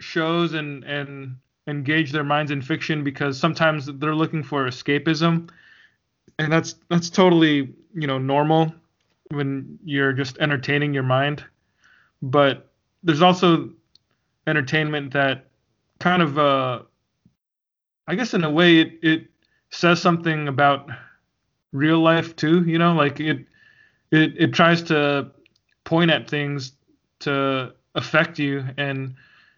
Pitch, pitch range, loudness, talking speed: 150 Hz, 140-165 Hz, -21 LUFS, 130 wpm